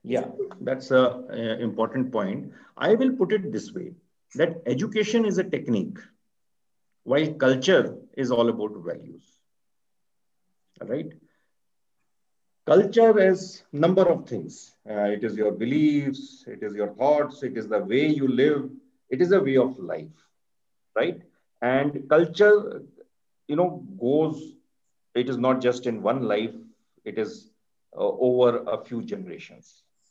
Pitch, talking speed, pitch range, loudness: 150 Hz, 140 wpm, 125-210 Hz, -24 LUFS